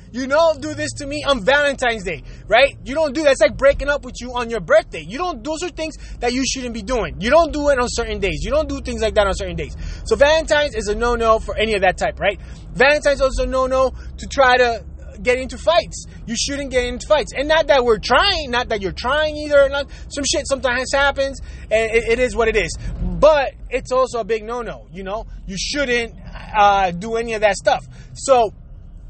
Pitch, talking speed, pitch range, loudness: 250 Hz, 235 wpm, 225-285 Hz, -18 LUFS